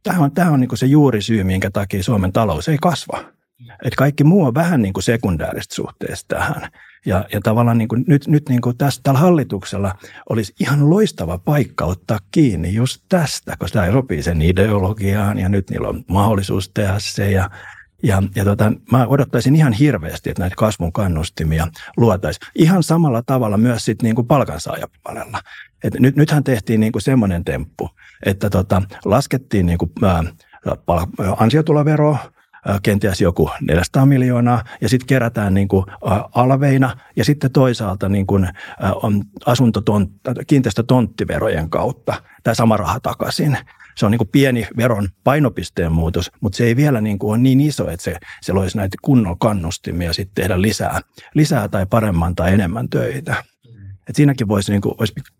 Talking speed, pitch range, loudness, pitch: 155 wpm, 100-130 Hz, -17 LUFS, 110 Hz